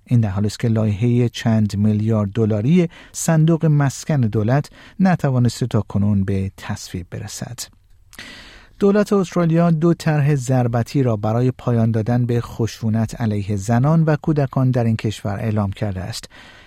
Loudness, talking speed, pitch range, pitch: -19 LUFS, 135 wpm, 105-145 Hz, 115 Hz